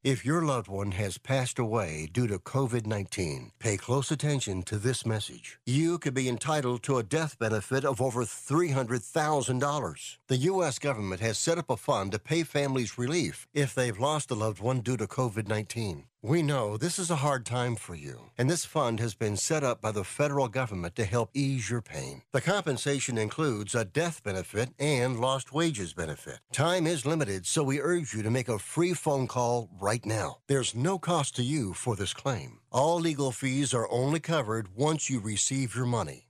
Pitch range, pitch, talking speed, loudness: 110-145 Hz, 130 Hz, 195 wpm, -30 LUFS